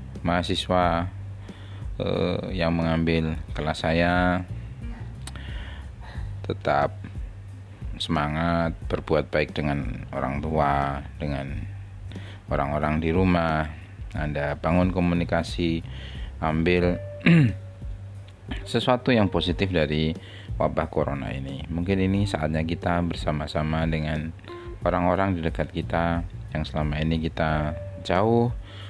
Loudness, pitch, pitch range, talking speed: -25 LUFS, 85 Hz, 80-100 Hz, 90 wpm